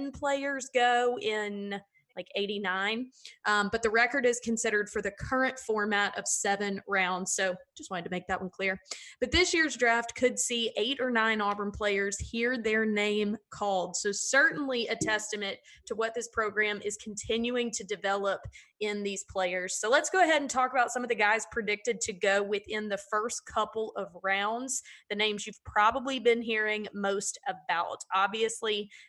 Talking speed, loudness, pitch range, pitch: 175 wpm, -29 LUFS, 200-240 Hz, 215 Hz